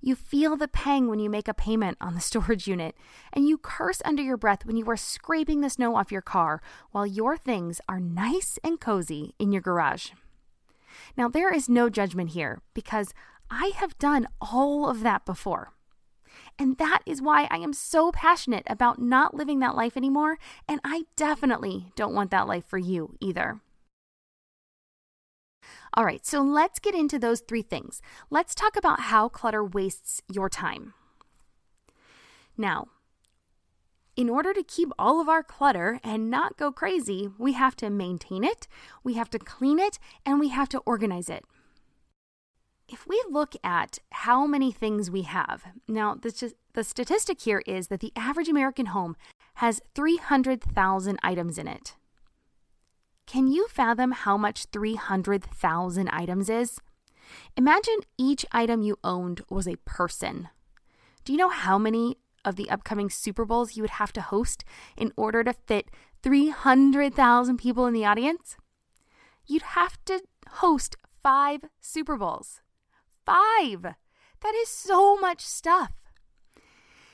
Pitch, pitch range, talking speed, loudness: 240 Hz, 200-295 Hz, 155 wpm, -26 LUFS